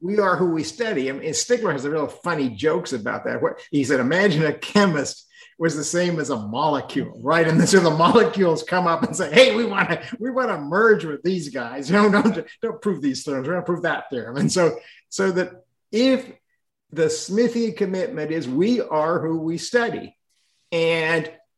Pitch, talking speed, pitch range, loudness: 175 Hz, 205 wpm, 155-225 Hz, -21 LUFS